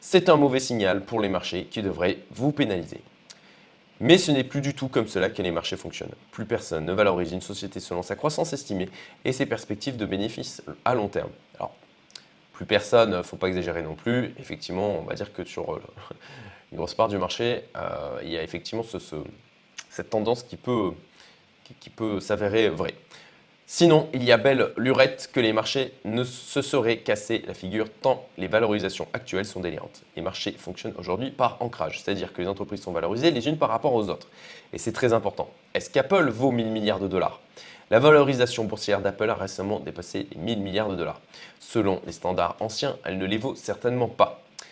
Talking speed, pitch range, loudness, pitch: 200 wpm, 100-130 Hz, -25 LUFS, 110 Hz